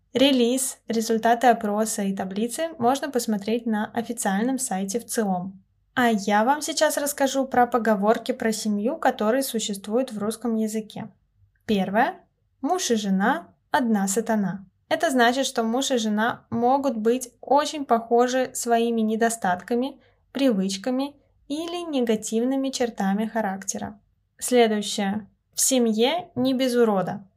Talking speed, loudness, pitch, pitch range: 120 wpm, -24 LUFS, 235 Hz, 215-260 Hz